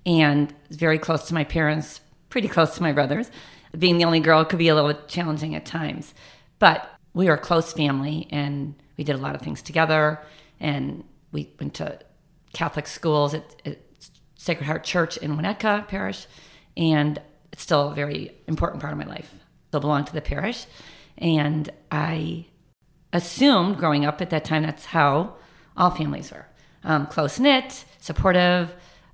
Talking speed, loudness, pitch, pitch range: 170 wpm, -23 LUFS, 155 Hz, 150-170 Hz